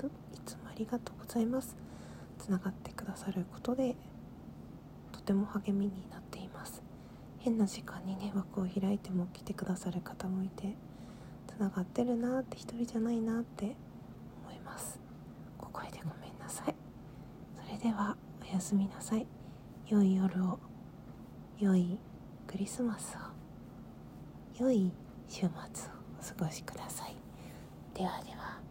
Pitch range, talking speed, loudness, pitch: 190-230 Hz, 250 characters per minute, -37 LUFS, 200 Hz